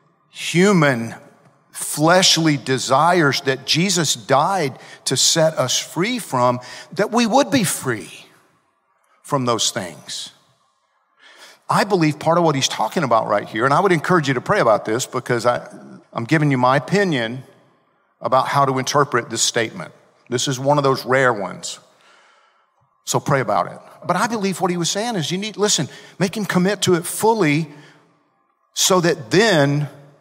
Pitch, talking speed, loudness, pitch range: 155 Hz, 165 wpm, -18 LUFS, 135-180 Hz